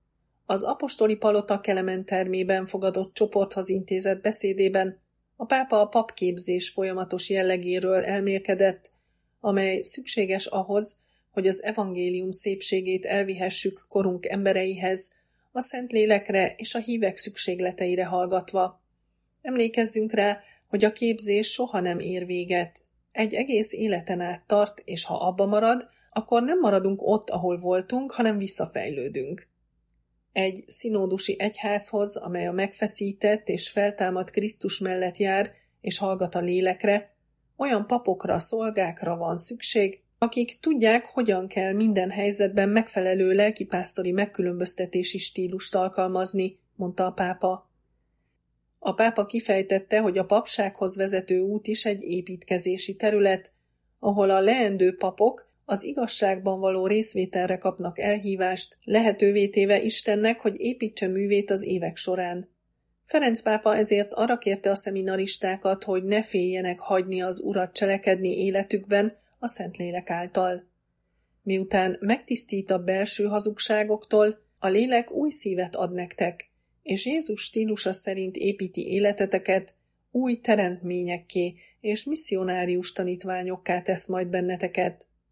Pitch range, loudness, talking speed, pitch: 185-210 Hz, -26 LUFS, 115 wpm, 195 Hz